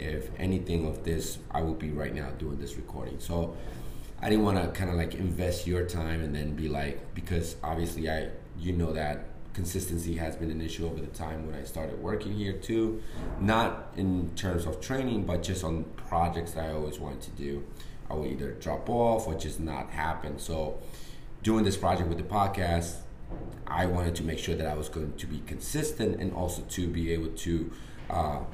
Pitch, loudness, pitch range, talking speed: 85 Hz, -32 LUFS, 80-90 Hz, 205 wpm